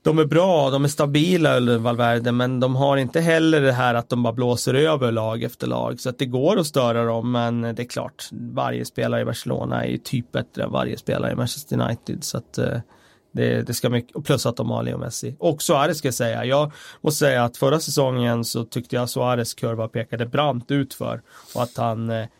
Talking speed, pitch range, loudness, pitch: 230 wpm, 115-140 Hz, -22 LUFS, 125 Hz